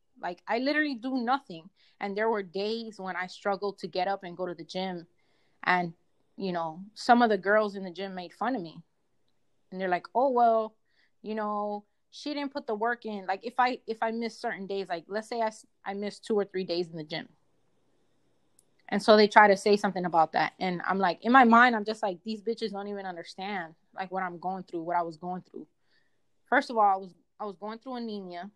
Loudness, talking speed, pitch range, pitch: -28 LUFS, 235 wpm, 185-225 Hz, 200 Hz